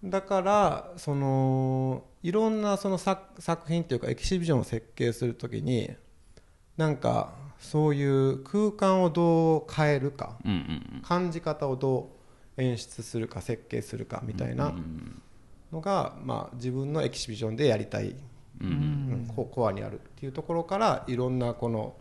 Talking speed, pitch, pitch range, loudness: 295 characters per minute, 135 Hz, 120-165 Hz, -29 LUFS